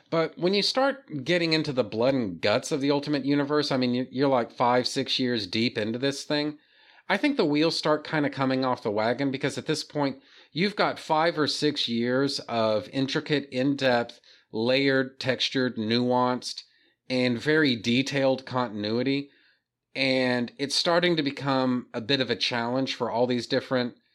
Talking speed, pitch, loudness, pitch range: 175 wpm, 135 Hz, -26 LUFS, 125-150 Hz